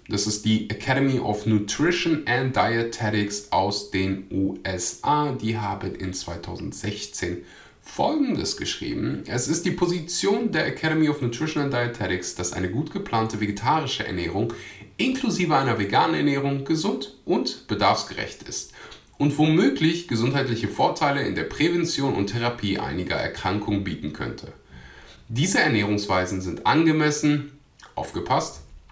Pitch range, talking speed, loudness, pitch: 100-150 Hz, 120 wpm, -24 LUFS, 115 Hz